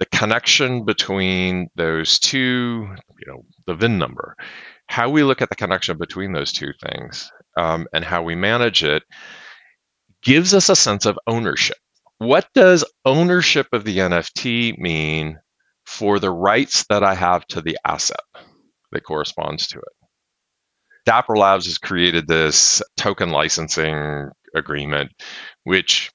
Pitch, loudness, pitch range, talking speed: 100 Hz, -17 LUFS, 85-120 Hz, 140 wpm